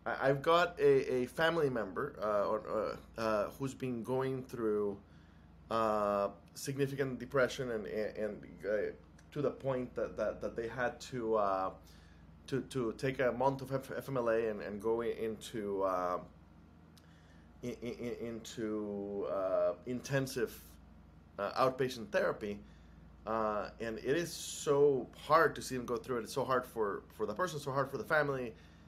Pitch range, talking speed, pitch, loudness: 90-135 Hz, 160 wpm, 115 Hz, -36 LUFS